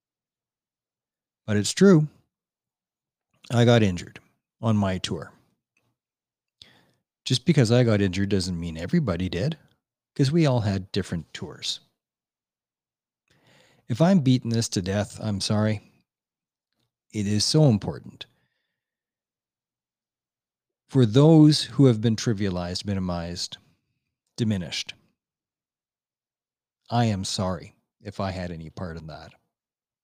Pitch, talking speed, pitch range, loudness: 105 Hz, 110 wpm, 95-130 Hz, -23 LUFS